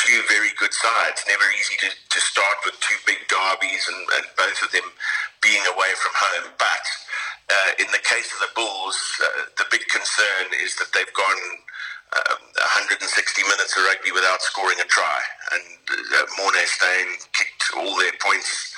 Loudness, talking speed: -20 LUFS, 175 wpm